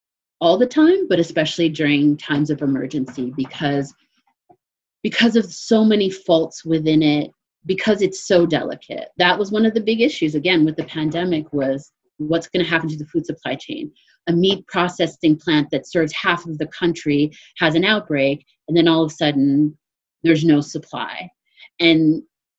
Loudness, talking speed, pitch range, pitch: -19 LUFS, 175 wpm, 150-195 Hz, 165 Hz